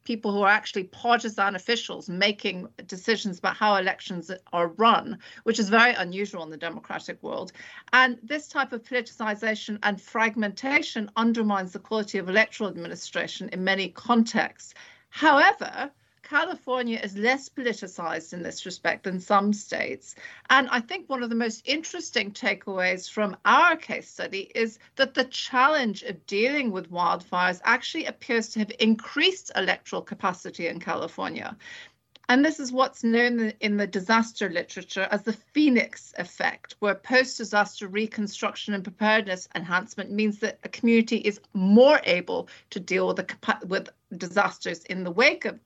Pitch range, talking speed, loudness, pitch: 195-245 Hz, 150 wpm, -25 LUFS, 215 Hz